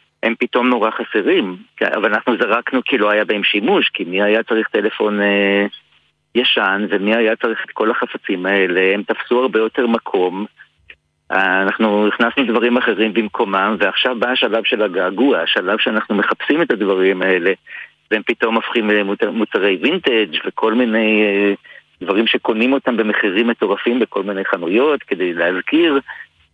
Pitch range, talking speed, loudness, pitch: 100-120 Hz, 145 wpm, -16 LUFS, 110 Hz